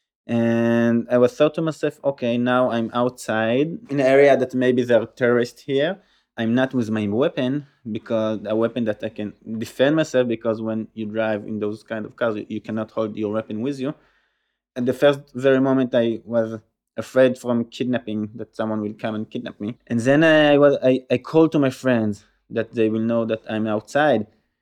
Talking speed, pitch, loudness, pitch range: 200 wpm, 115 Hz, -21 LUFS, 110-130 Hz